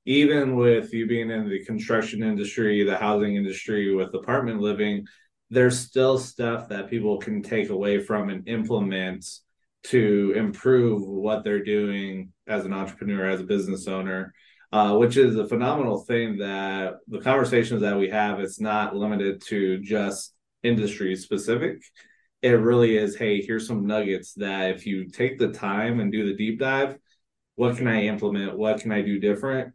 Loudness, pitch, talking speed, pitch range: -24 LUFS, 105 Hz, 165 wpm, 100-115 Hz